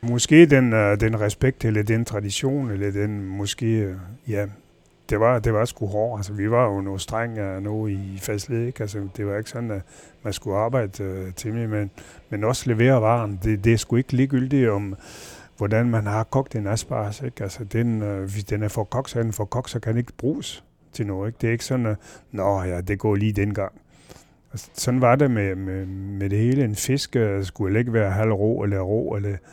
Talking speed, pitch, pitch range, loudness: 205 wpm, 110 Hz, 100-120 Hz, -23 LUFS